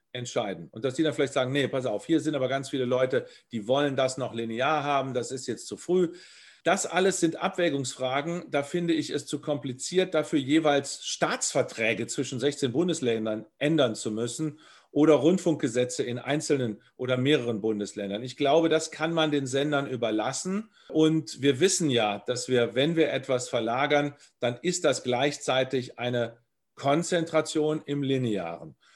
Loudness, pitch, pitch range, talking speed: -27 LUFS, 140 Hz, 125-155 Hz, 165 wpm